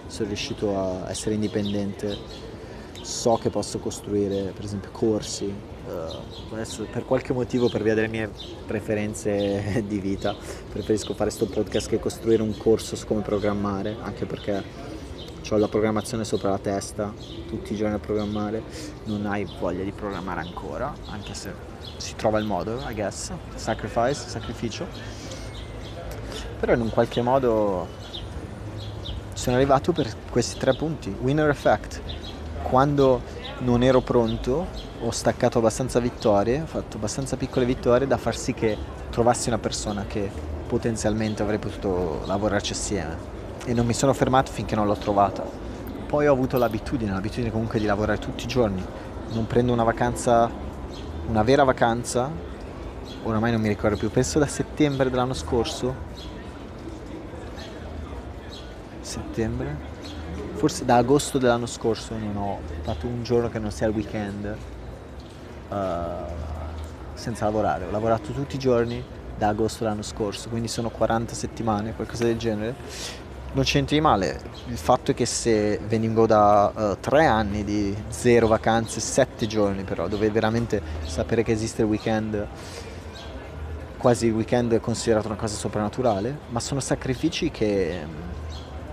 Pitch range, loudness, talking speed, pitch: 100-115 Hz, -25 LUFS, 145 wpm, 110 Hz